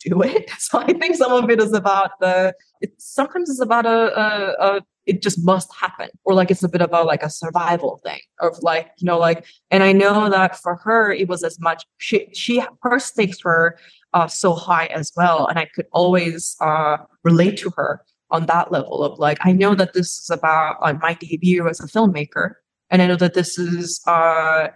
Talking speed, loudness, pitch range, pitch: 215 wpm, -18 LUFS, 165-200 Hz, 180 Hz